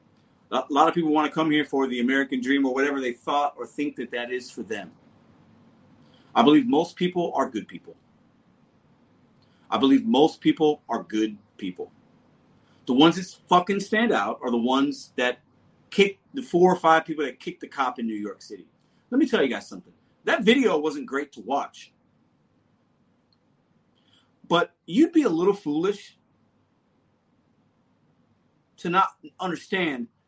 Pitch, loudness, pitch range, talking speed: 155 Hz, -24 LUFS, 130-190 Hz, 165 wpm